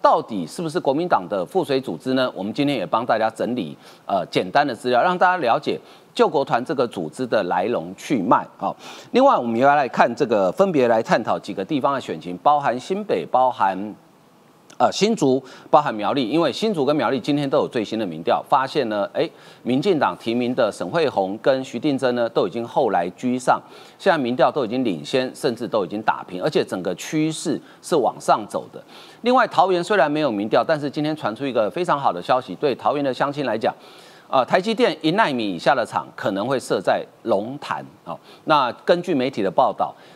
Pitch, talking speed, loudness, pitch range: 135 Hz, 315 characters per minute, -21 LUFS, 120-160 Hz